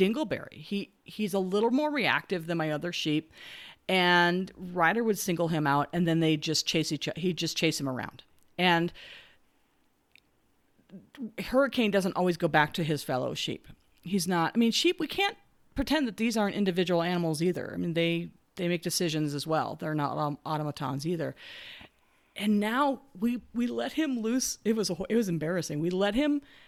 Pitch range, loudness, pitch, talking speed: 160-225 Hz, -29 LUFS, 180 Hz, 185 wpm